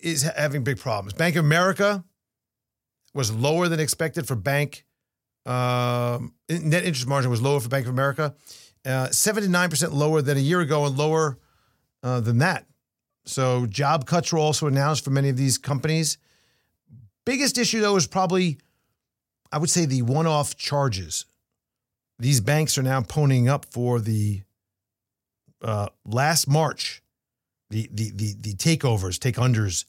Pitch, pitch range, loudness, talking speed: 140 Hz, 120-155 Hz, -23 LUFS, 150 wpm